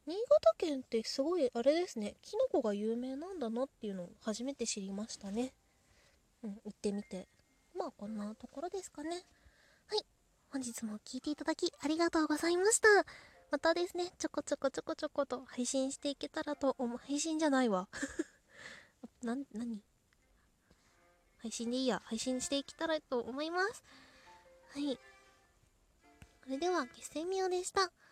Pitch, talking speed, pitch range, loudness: 275 Hz, 325 characters per minute, 235-325 Hz, -36 LUFS